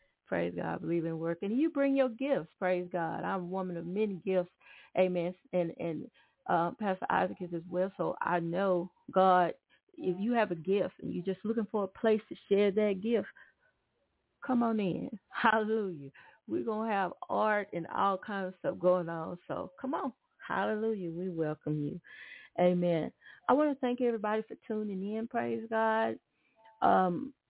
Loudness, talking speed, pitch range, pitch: -33 LUFS, 175 wpm, 175-220 Hz, 190 Hz